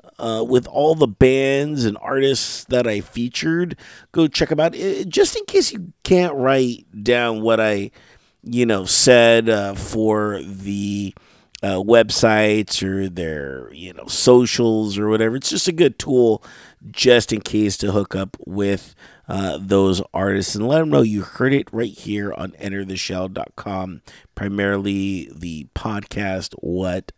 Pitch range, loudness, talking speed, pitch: 100-125 Hz, -19 LUFS, 150 wpm, 110 Hz